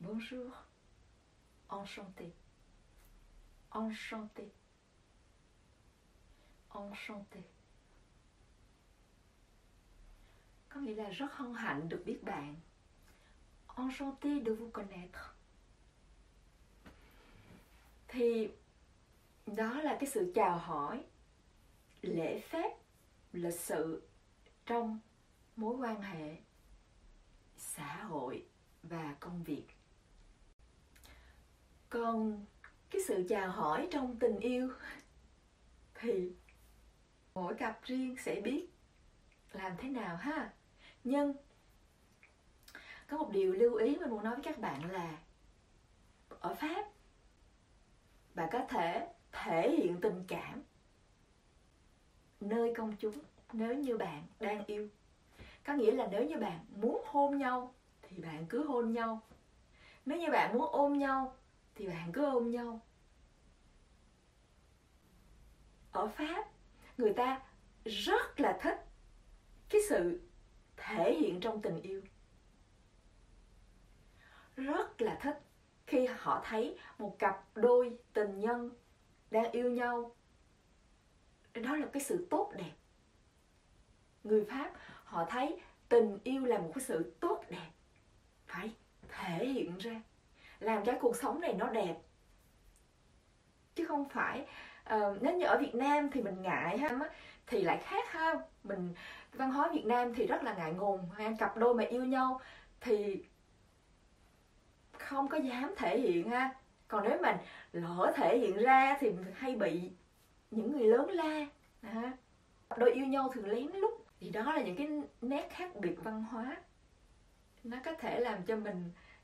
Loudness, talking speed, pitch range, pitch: -37 LUFS, 125 wpm, 195-275 Hz, 230 Hz